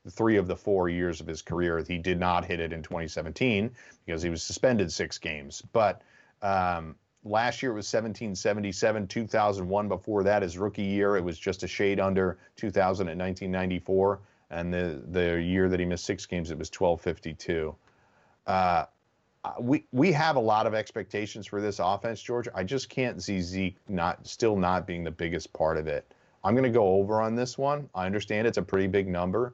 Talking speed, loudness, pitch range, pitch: 195 wpm, -29 LUFS, 90-105 Hz, 95 Hz